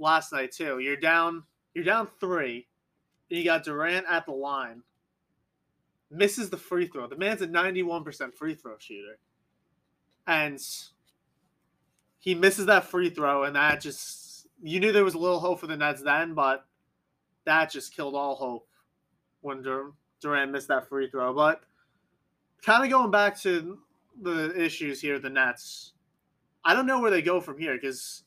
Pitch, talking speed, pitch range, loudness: 165 Hz, 170 wpm, 140-180 Hz, -27 LUFS